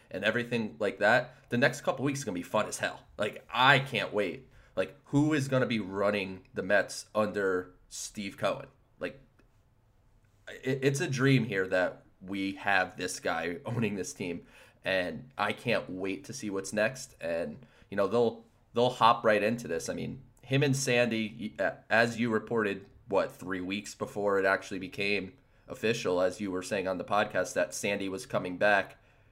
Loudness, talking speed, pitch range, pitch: -30 LUFS, 180 wpm, 95-120 Hz, 105 Hz